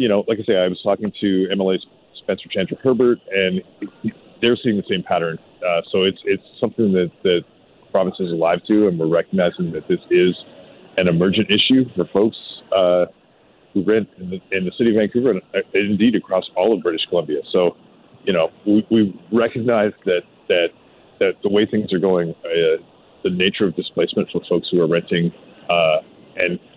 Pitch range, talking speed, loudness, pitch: 90-120 Hz, 190 wpm, -19 LUFS, 100 Hz